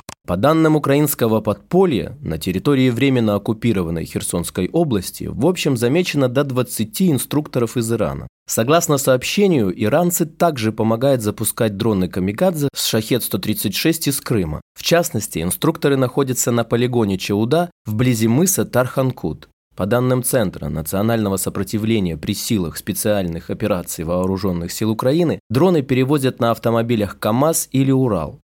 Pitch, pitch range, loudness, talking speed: 120 Hz, 105-140 Hz, -18 LUFS, 125 wpm